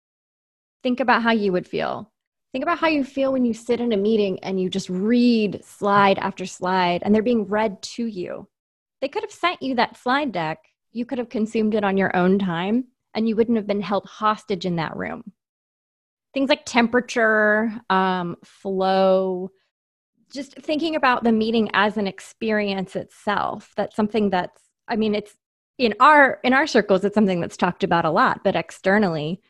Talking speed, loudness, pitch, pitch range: 185 wpm, -21 LUFS, 215 Hz, 190-240 Hz